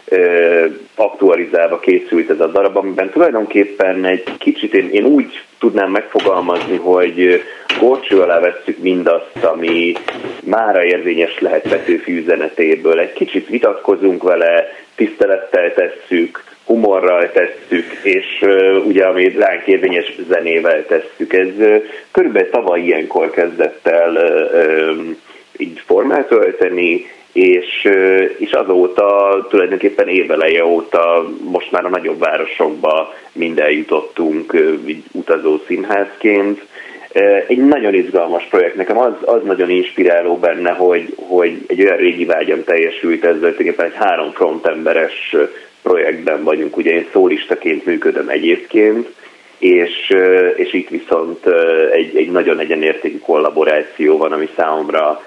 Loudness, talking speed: -13 LUFS, 115 wpm